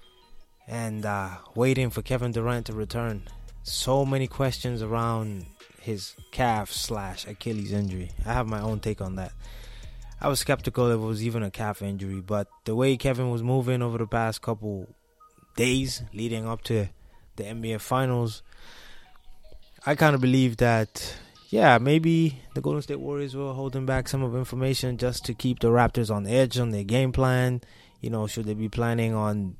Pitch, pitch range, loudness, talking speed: 115 Hz, 105-130 Hz, -27 LUFS, 175 wpm